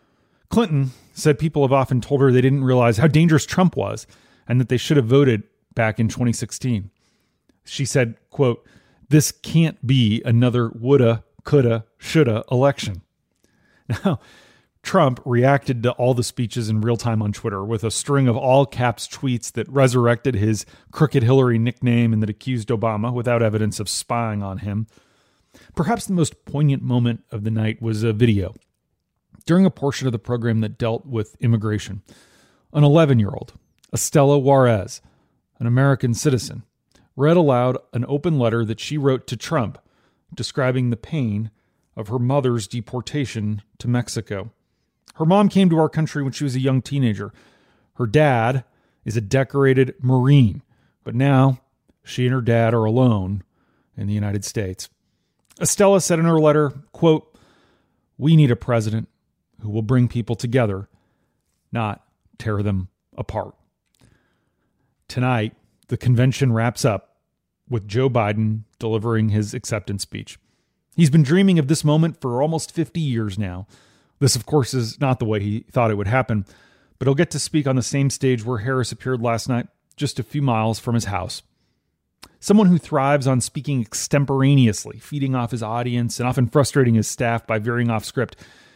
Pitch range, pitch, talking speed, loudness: 110-140 Hz, 125 Hz, 160 wpm, -20 LUFS